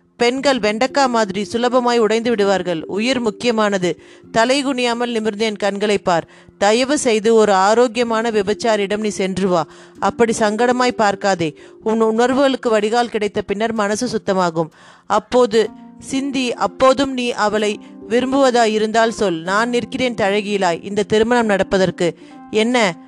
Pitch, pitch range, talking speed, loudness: 220 Hz, 205-245 Hz, 120 wpm, -17 LUFS